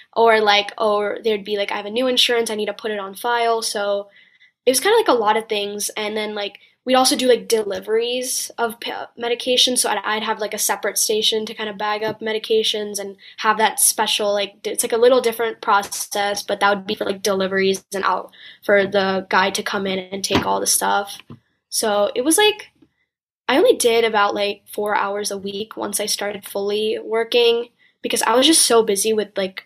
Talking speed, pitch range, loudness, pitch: 225 wpm, 200-230 Hz, -19 LUFS, 215 Hz